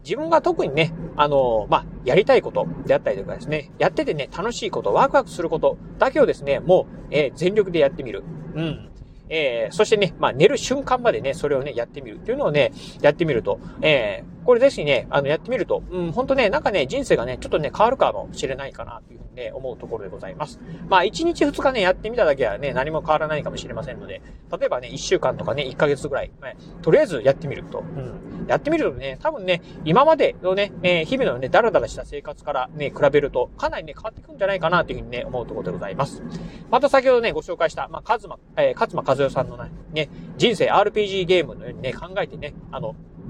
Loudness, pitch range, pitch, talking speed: -21 LUFS, 150-230 Hz, 175 Hz, 465 characters per minute